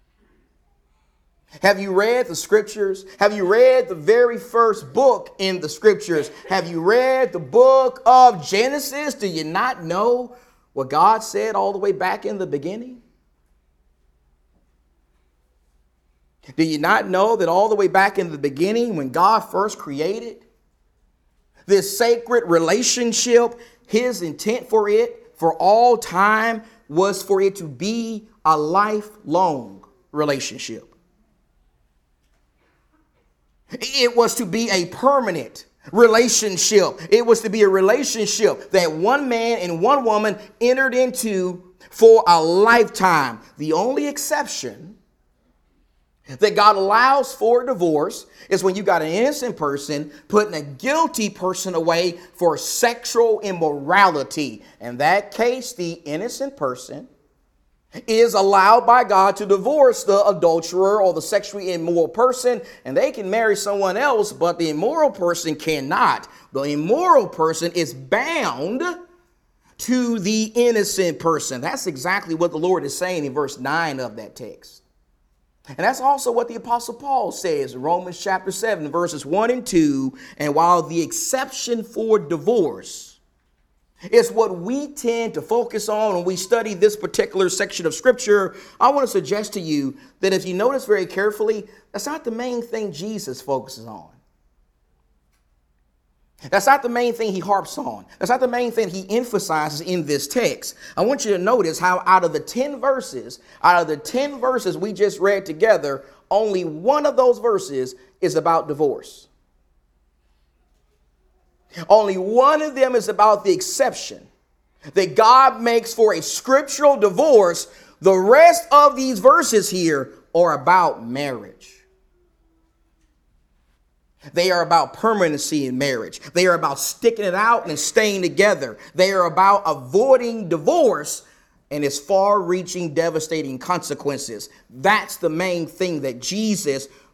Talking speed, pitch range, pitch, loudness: 145 wpm, 155-235 Hz, 195 Hz, -19 LUFS